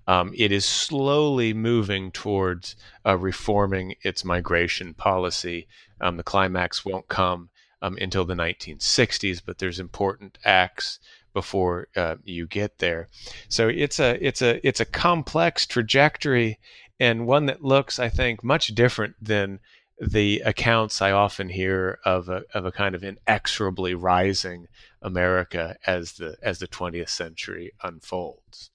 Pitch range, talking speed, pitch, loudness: 90-115 Hz, 140 wpm, 95 Hz, -24 LUFS